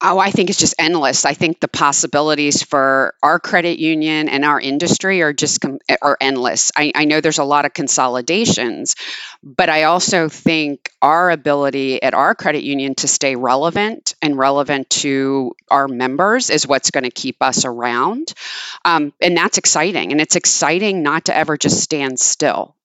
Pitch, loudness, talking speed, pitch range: 150 Hz, -15 LUFS, 180 wpm, 135-170 Hz